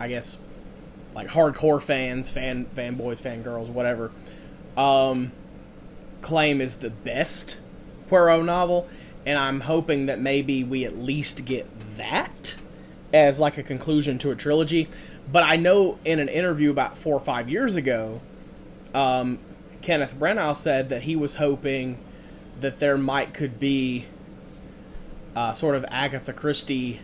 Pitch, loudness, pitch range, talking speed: 135 Hz, -24 LUFS, 125-150 Hz, 140 wpm